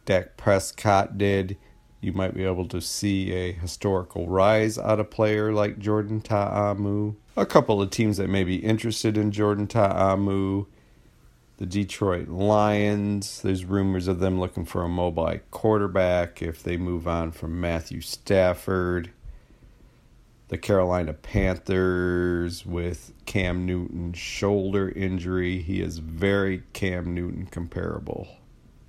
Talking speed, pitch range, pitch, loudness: 130 wpm, 90-100 Hz, 95 Hz, -25 LUFS